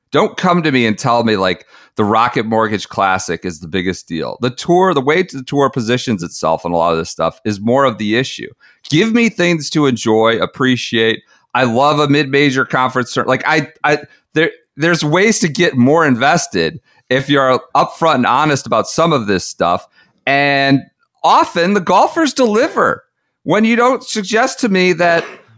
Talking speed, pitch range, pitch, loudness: 185 wpm, 115-180 Hz, 140 Hz, -14 LUFS